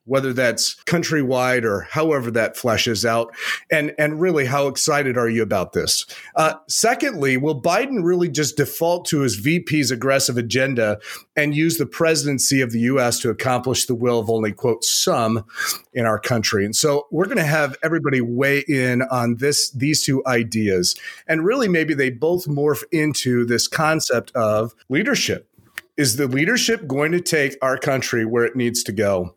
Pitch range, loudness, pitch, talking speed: 120-150 Hz, -19 LUFS, 135 Hz, 175 wpm